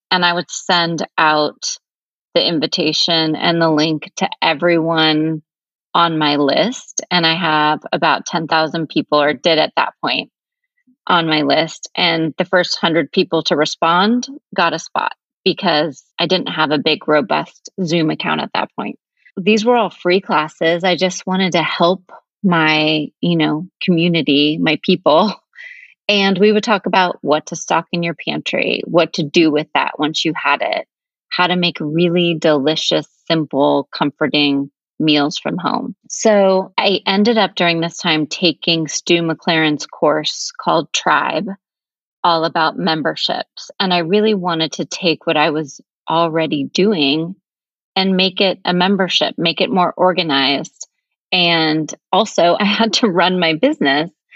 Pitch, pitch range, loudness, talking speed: 170 Hz, 155-190 Hz, -16 LUFS, 155 wpm